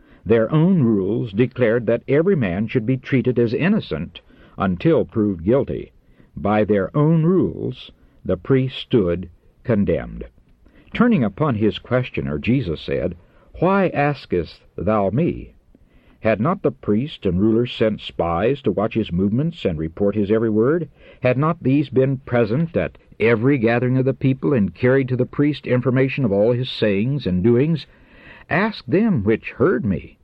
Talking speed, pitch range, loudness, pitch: 155 wpm, 105-140 Hz, -20 LUFS, 125 Hz